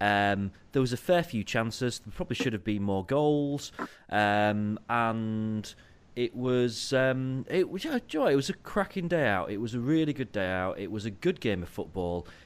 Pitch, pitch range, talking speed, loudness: 115 Hz, 105-140 Hz, 200 wpm, -29 LUFS